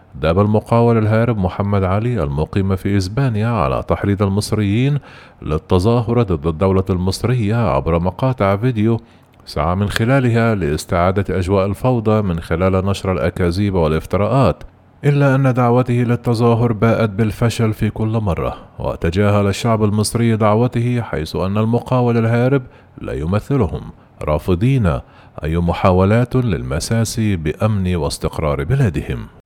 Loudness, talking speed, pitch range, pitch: -17 LUFS, 110 wpm, 95-120 Hz, 105 Hz